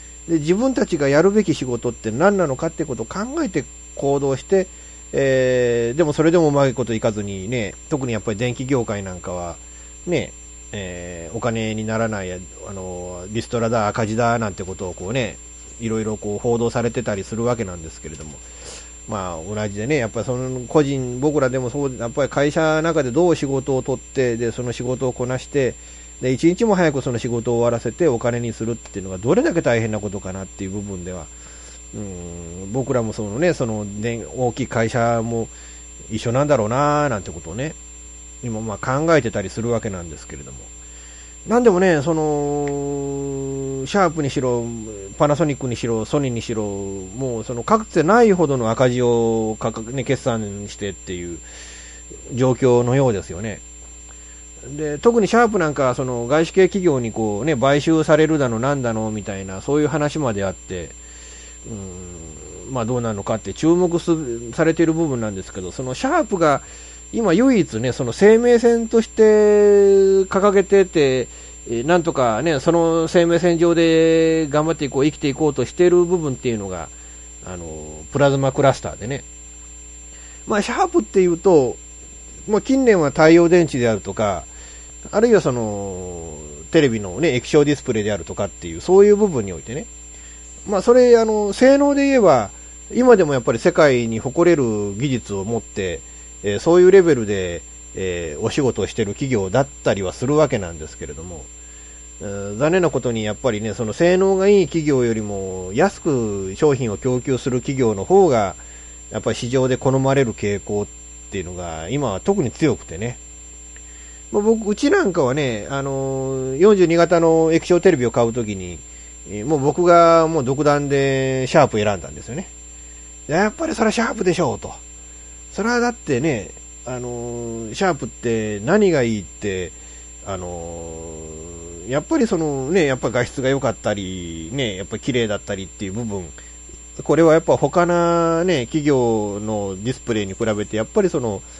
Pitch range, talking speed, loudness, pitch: 95-150 Hz, 345 characters per minute, -19 LUFS, 120 Hz